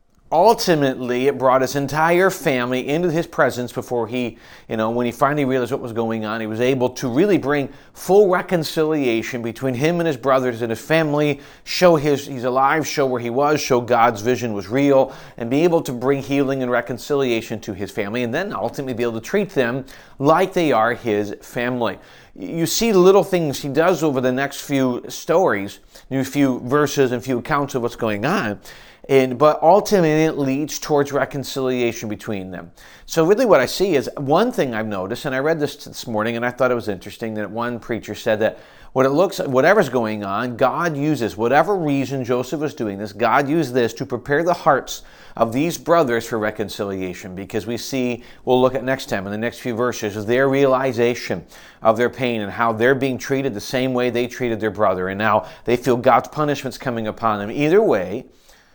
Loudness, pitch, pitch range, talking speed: -19 LUFS, 130 Hz, 115-145 Hz, 205 wpm